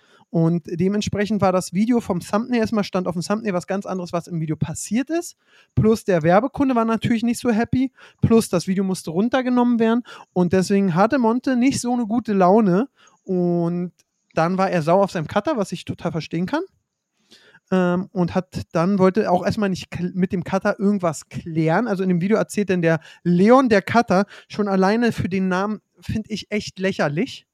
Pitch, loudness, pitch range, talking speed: 195 Hz, -21 LUFS, 180-220 Hz, 190 wpm